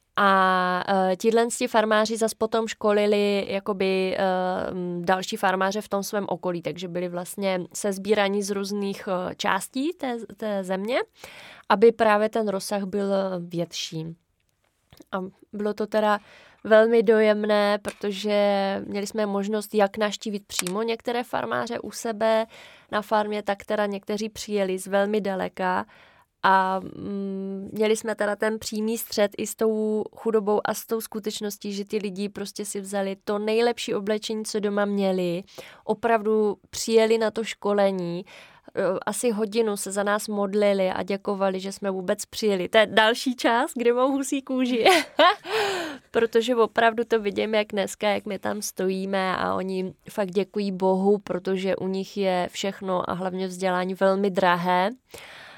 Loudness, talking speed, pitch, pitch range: -24 LUFS, 145 wpm, 205 Hz, 195-220 Hz